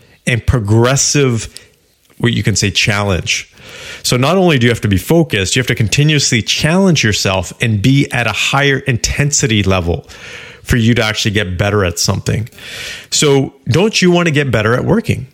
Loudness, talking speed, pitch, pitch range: -13 LUFS, 180 wpm, 120 Hz, 105-140 Hz